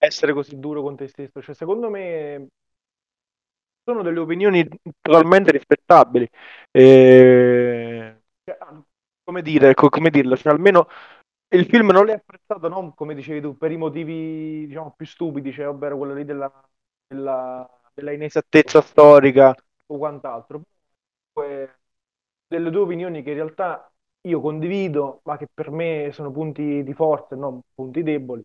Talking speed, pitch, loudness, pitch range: 145 wpm, 150 Hz, -16 LUFS, 140-165 Hz